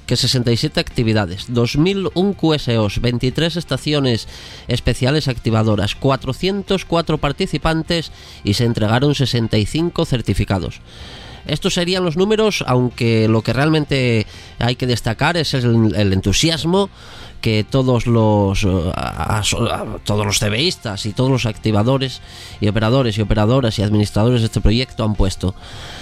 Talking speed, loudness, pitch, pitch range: 115 wpm, -17 LUFS, 120 Hz, 105-145 Hz